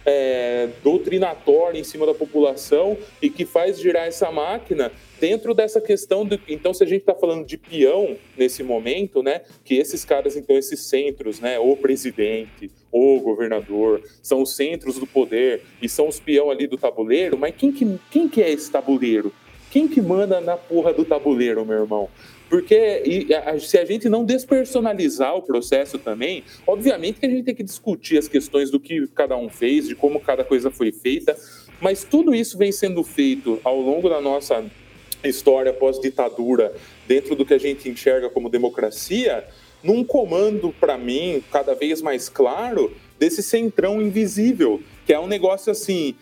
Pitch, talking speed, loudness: 185 Hz, 170 wpm, -20 LUFS